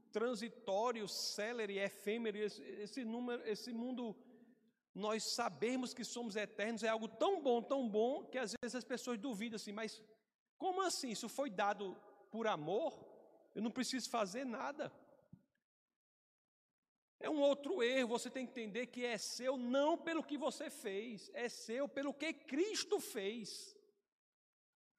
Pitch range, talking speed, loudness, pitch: 220-270 Hz, 145 wpm, -41 LUFS, 240 Hz